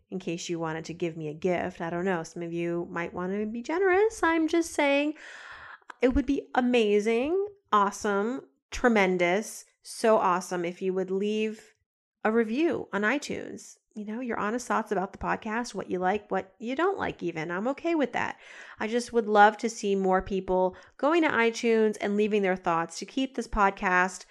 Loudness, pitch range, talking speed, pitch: -27 LUFS, 185-250 Hz, 195 wpm, 210 Hz